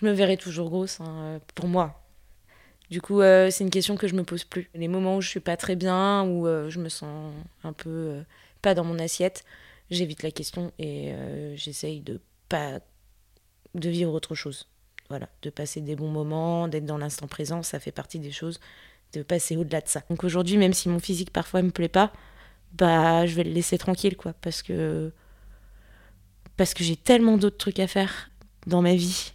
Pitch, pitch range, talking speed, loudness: 170 Hz, 150-185 Hz, 205 wpm, -26 LUFS